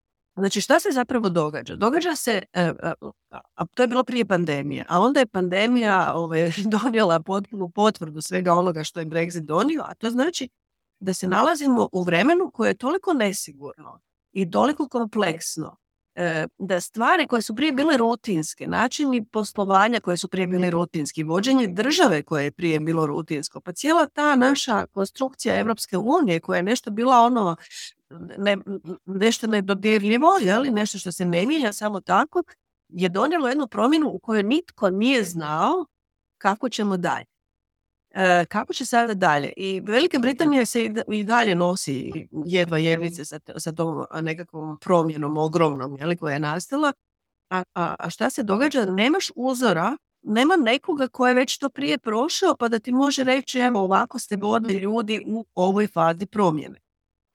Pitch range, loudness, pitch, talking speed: 175-250 Hz, -22 LUFS, 205 Hz, 160 wpm